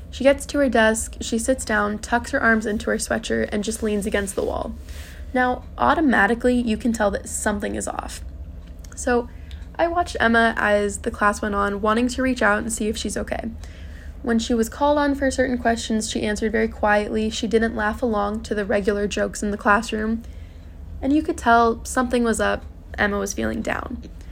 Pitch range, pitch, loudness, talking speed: 200-235 Hz, 220 Hz, -22 LUFS, 200 wpm